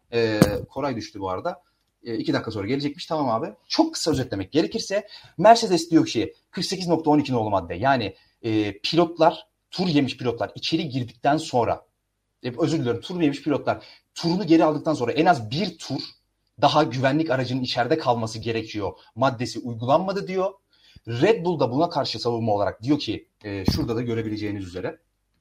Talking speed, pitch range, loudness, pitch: 160 wpm, 115-165 Hz, -24 LUFS, 135 Hz